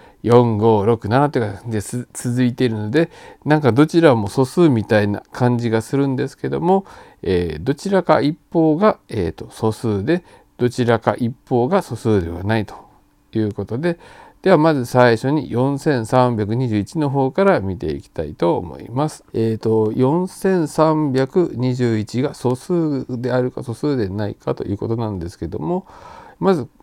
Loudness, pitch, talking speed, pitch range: -19 LUFS, 125 Hz, 315 characters per minute, 110-150 Hz